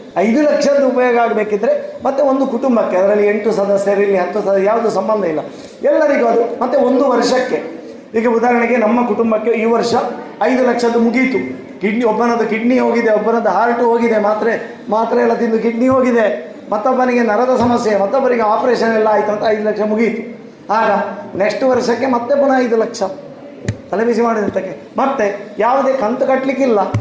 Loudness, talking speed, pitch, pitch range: -14 LUFS, 145 wpm, 230 Hz, 210-250 Hz